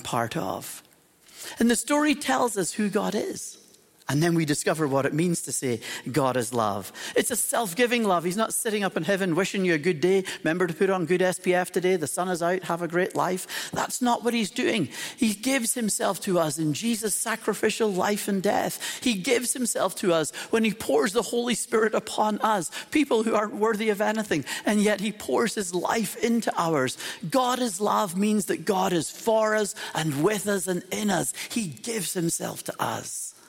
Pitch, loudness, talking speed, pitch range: 205 Hz, -25 LUFS, 210 wpm, 175-225 Hz